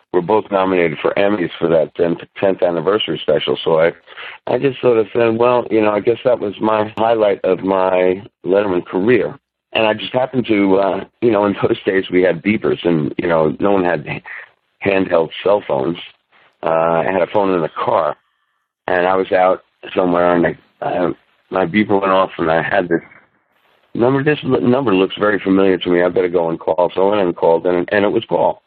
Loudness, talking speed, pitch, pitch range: -16 LUFS, 210 wpm, 95 Hz, 90-110 Hz